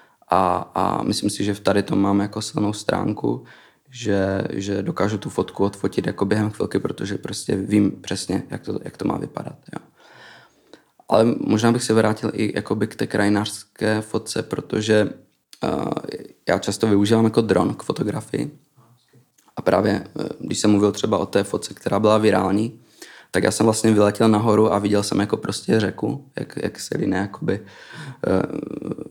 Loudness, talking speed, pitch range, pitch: -21 LUFS, 165 wpm, 100-110 Hz, 105 Hz